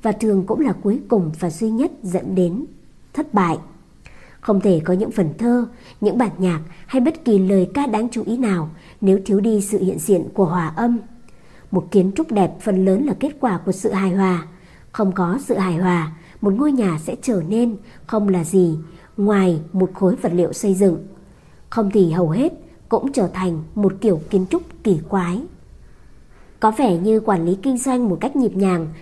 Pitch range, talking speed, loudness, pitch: 180-225 Hz, 205 wpm, -19 LUFS, 195 Hz